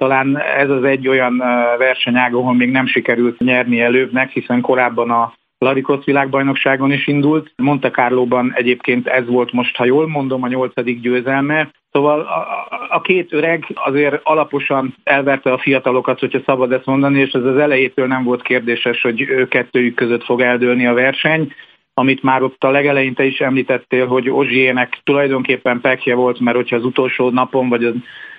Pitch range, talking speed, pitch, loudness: 125-140 Hz, 170 wpm, 130 Hz, -15 LUFS